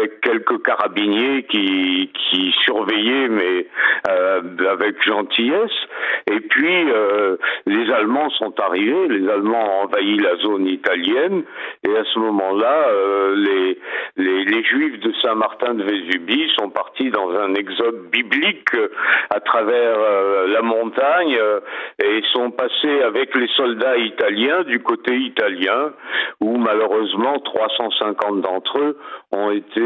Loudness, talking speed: -18 LUFS, 125 wpm